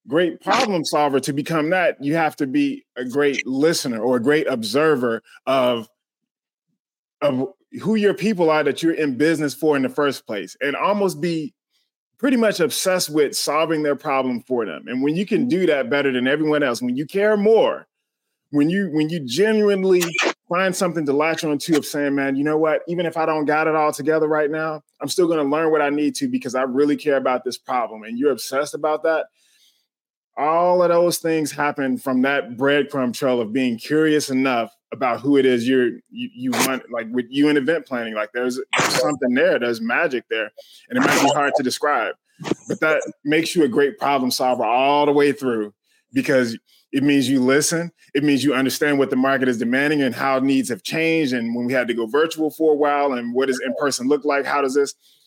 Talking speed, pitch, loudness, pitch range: 215 wpm, 145 Hz, -20 LUFS, 135-160 Hz